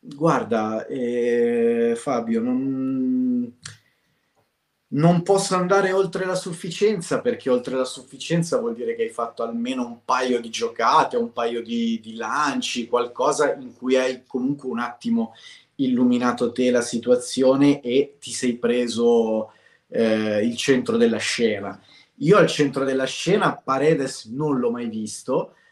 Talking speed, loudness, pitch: 140 wpm, -22 LUFS, 140 Hz